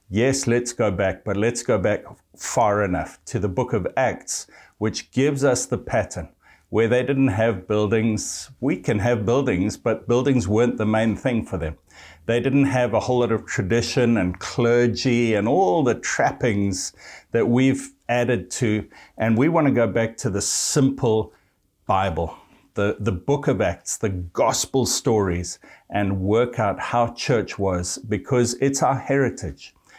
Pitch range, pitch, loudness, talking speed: 100-125 Hz, 115 Hz, -22 LUFS, 165 wpm